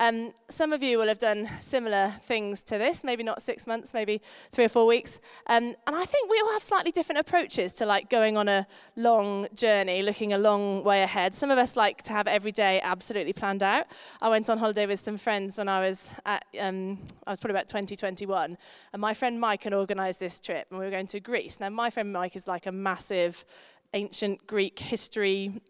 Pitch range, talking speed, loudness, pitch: 195-230 Hz, 225 wpm, -27 LUFS, 210 Hz